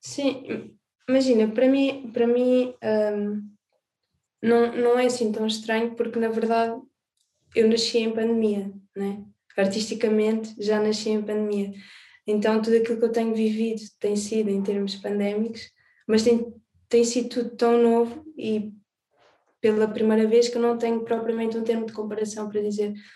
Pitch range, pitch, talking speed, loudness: 215-235 Hz, 225 Hz, 155 wpm, -24 LUFS